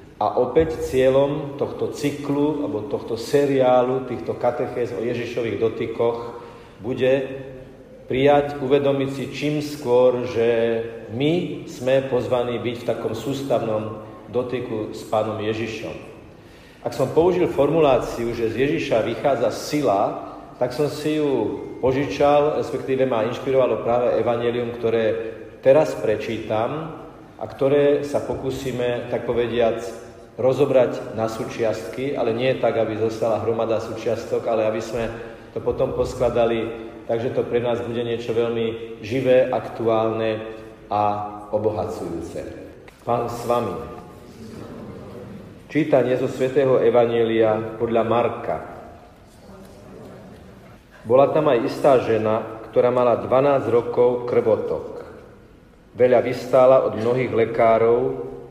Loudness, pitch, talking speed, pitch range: -21 LUFS, 120 Hz, 115 wpm, 115-135 Hz